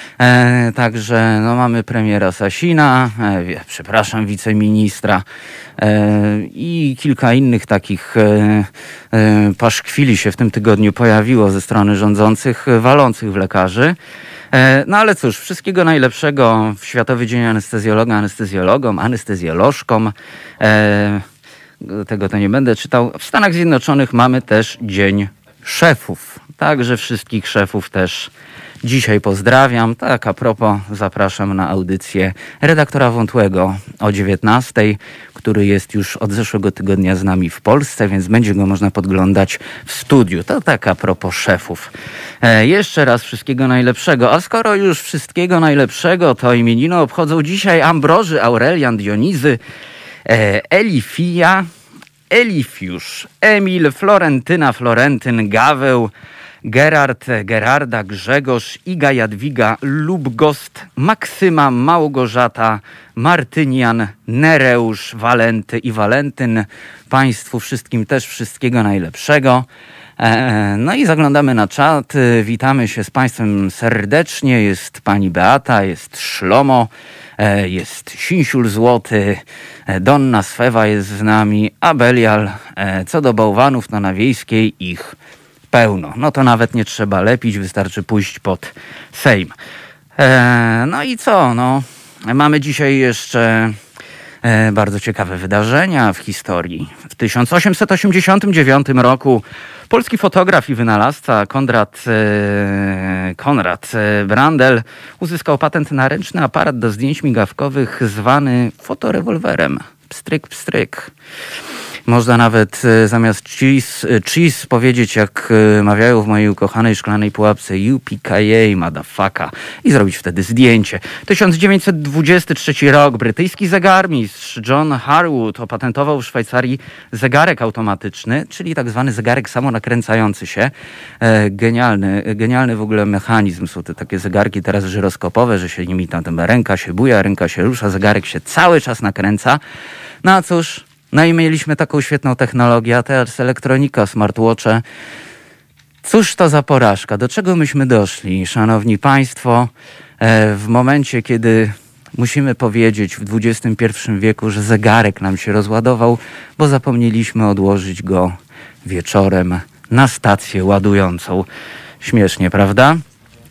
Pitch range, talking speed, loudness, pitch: 105-135 Hz, 115 wpm, -13 LUFS, 115 Hz